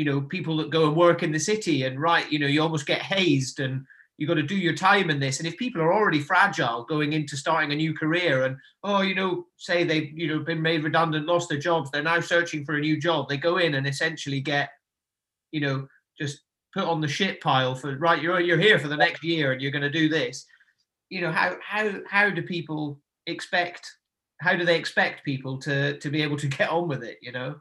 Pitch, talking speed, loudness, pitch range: 160 Hz, 250 wpm, -24 LUFS, 145-170 Hz